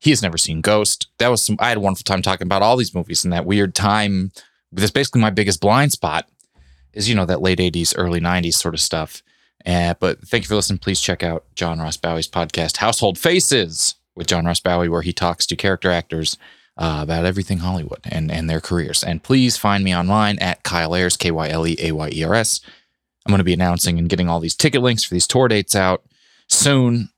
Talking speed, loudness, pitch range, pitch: 235 wpm, -18 LUFS, 85-105 Hz, 90 Hz